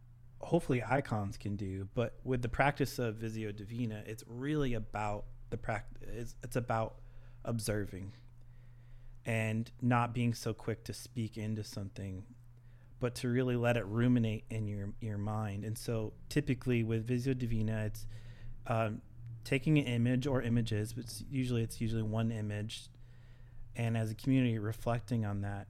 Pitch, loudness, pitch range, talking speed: 115 Hz, -36 LUFS, 110-120 Hz, 155 wpm